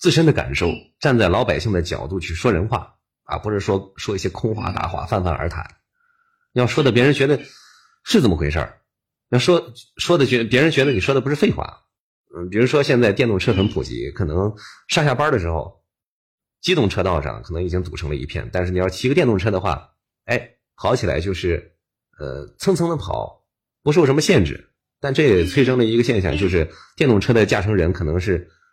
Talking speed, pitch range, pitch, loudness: 305 characters per minute, 90-135 Hz, 105 Hz, -19 LUFS